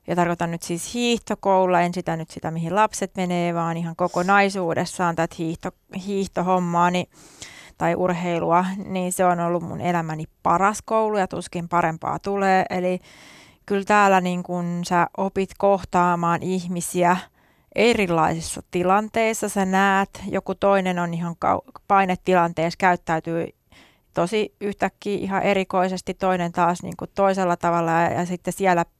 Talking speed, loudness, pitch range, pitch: 130 wpm, -22 LUFS, 175-195 Hz, 180 Hz